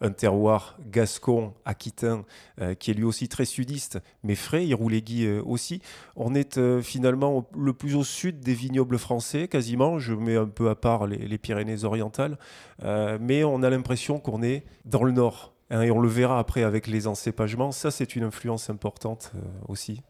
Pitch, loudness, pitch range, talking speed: 115 Hz, -27 LUFS, 110-130 Hz, 190 wpm